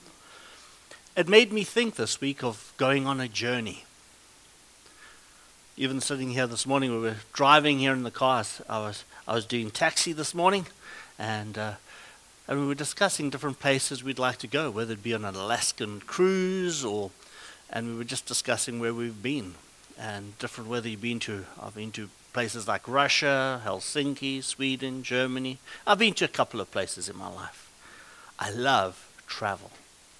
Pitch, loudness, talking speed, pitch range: 130 Hz, -28 LUFS, 175 wpm, 115-140 Hz